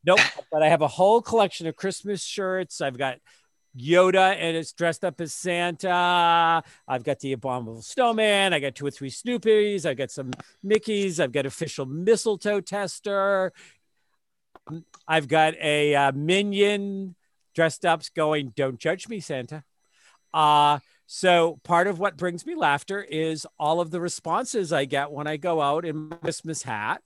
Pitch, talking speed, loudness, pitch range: 165 Hz, 160 wpm, -24 LUFS, 150-195 Hz